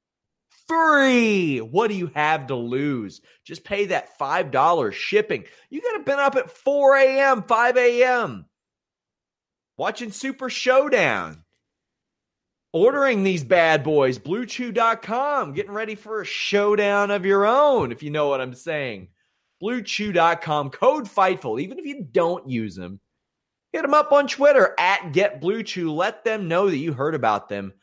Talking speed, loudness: 145 wpm, -21 LUFS